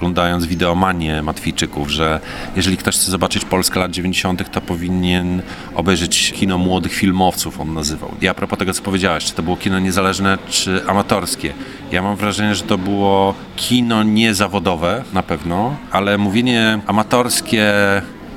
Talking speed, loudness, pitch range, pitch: 145 wpm, -17 LUFS, 90-100 Hz, 95 Hz